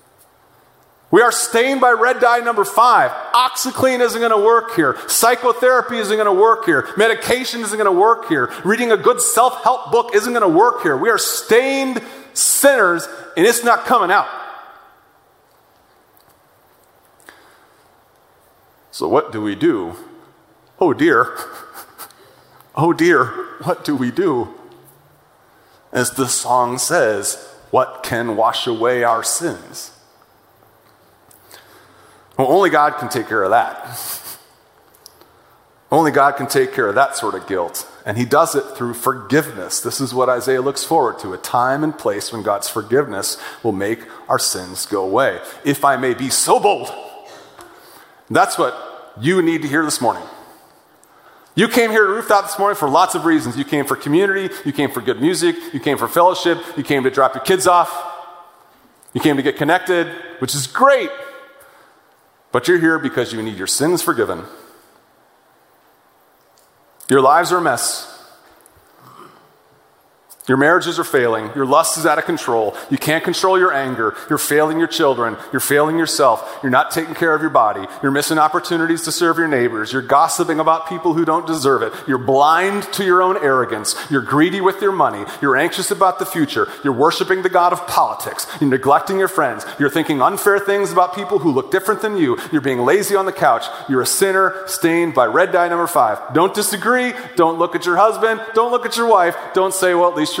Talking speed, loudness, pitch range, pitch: 175 wpm, -16 LUFS, 150-230 Hz, 180 Hz